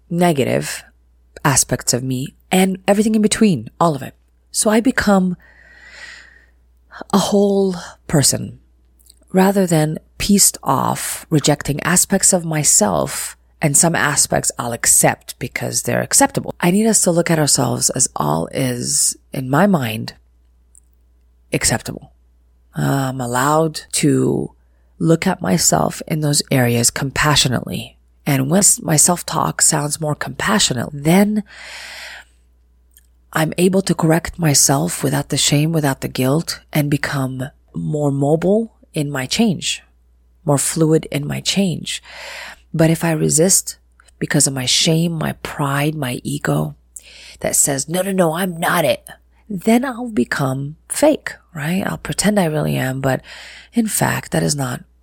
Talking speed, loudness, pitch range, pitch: 135 wpm, -16 LUFS, 125-180 Hz, 150 Hz